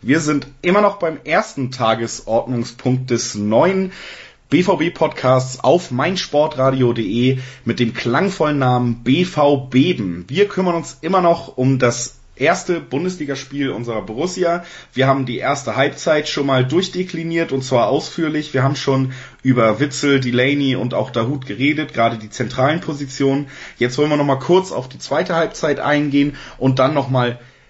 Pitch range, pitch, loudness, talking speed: 125-155 Hz, 135 Hz, -18 LUFS, 145 wpm